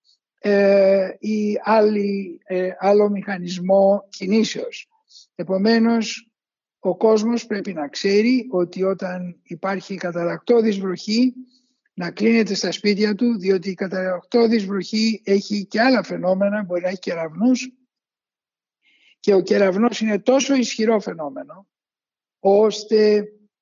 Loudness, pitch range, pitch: -20 LUFS, 190-225 Hz, 205 Hz